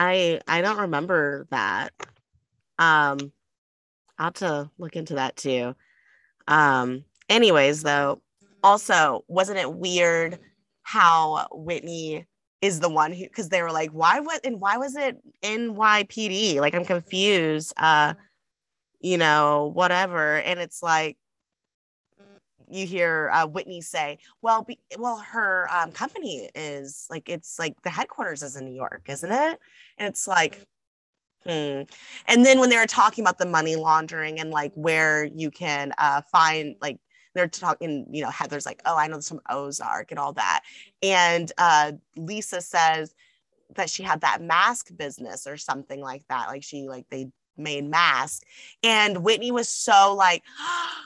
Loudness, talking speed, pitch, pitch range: -23 LUFS, 155 wpm, 170 Hz, 150-195 Hz